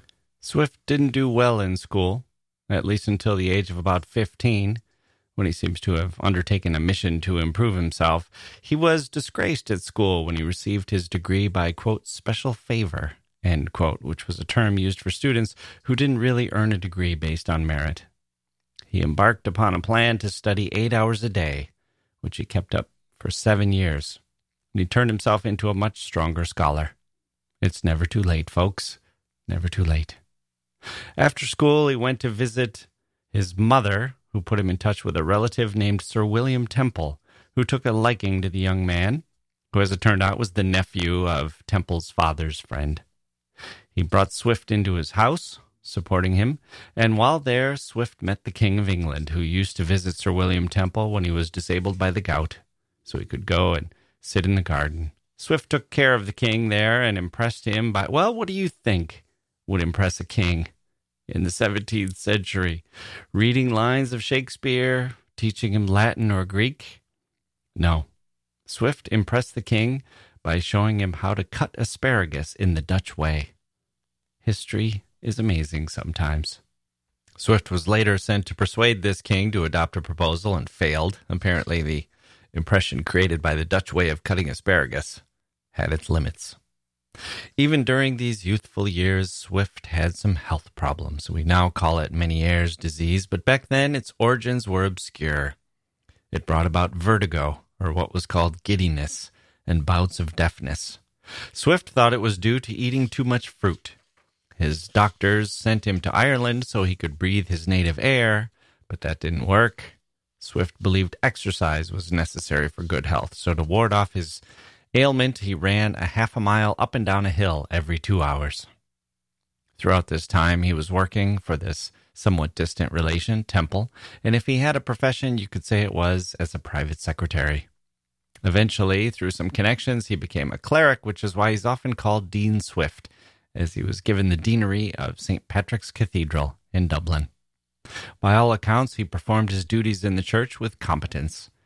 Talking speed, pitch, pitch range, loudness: 175 wpm, 95 Hz, 85-110 Hz, -23 LUFS